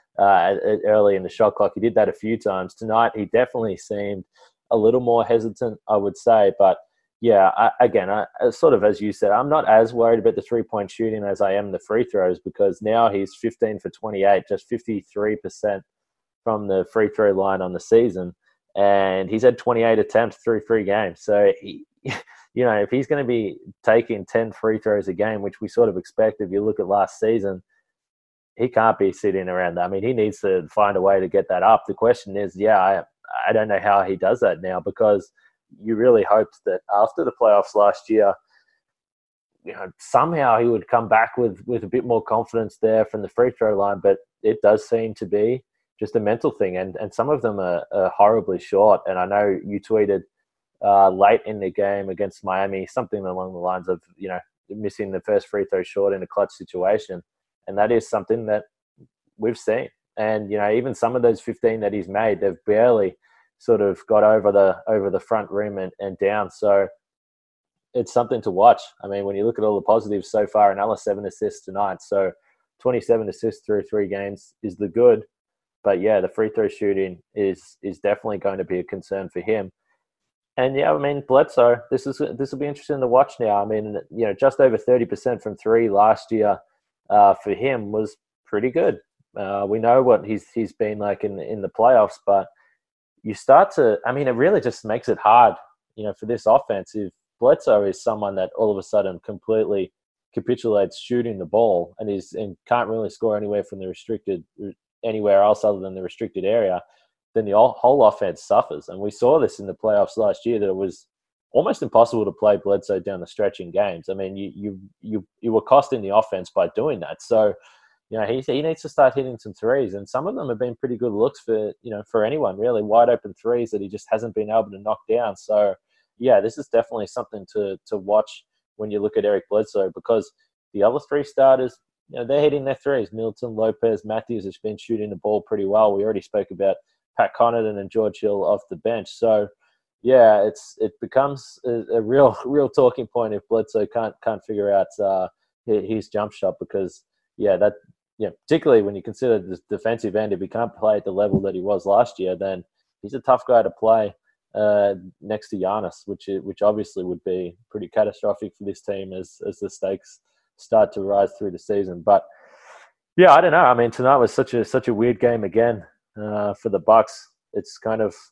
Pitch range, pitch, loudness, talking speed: 100-120 Hz, 110 Hz, -20 LUFS, 215 wpm